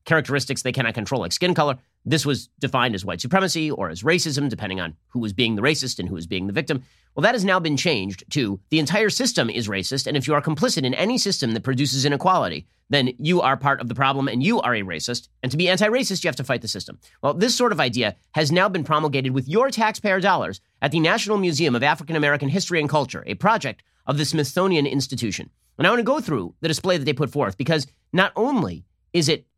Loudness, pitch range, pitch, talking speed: -22 LUFS, 125-165 Hz, 145 Hz, 245 wpm